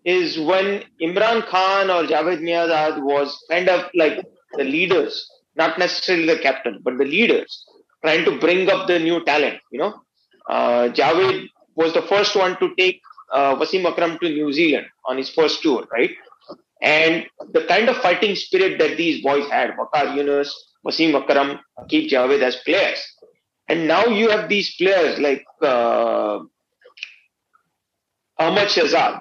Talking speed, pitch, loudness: 155 wpm, 180 Hz, -19 LUFS